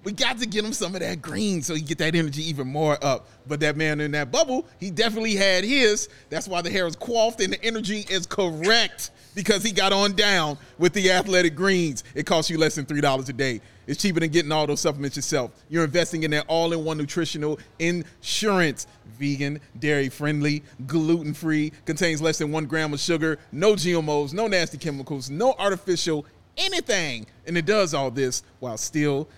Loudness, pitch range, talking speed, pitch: -24 LUFS, 145-190 Hz, 200 wpm, 160 Hz